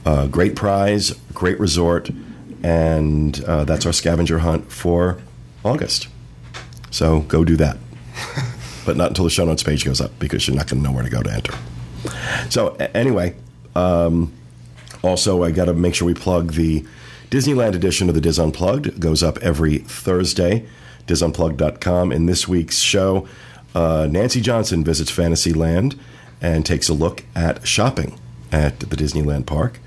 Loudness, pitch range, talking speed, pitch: -19 LUFS, 75-90 Hz, 165 wpm, 85 Hz